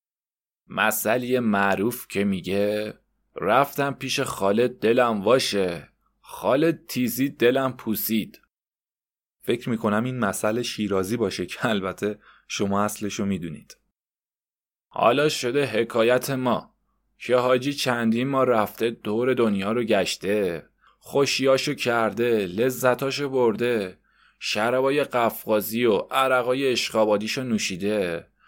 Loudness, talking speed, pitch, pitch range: -23 LUFS, 100 wpm, 120 Hz, 105-130 Hz